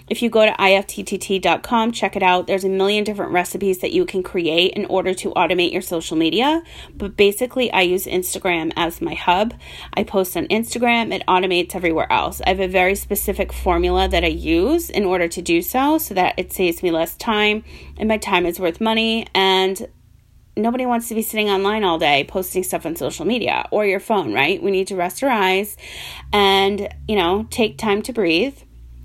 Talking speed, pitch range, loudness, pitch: 200 wpm, 180-215 Hz, -19 LUFS, 195 Hz